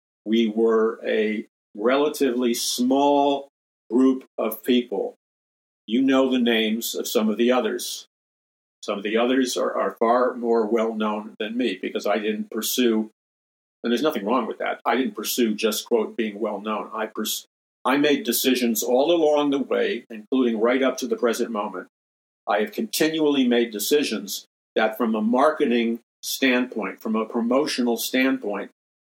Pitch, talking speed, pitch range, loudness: 120 Hz, 160 wpm, 110-130 Hz, -23 LUFS